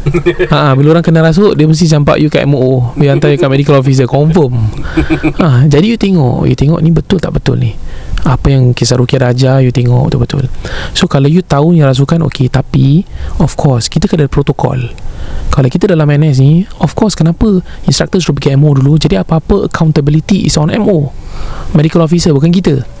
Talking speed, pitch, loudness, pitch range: 195 wpm, 150 Hz, -9 LUFS, 135-165 Hz